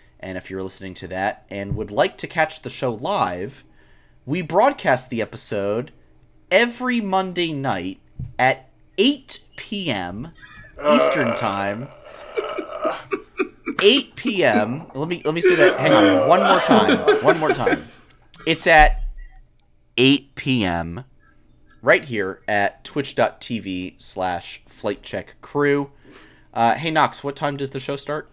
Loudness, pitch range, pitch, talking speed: -20 LUFS, 105-165 Hz, 140 Hz, 125 wpm